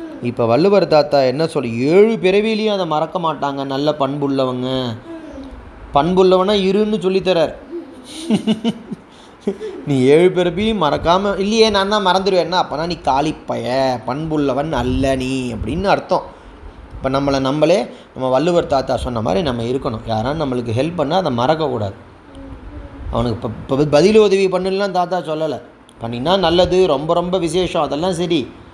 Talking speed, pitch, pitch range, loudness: 130 wpm, 155 Hz, 130-190 Hz, -17 LUFS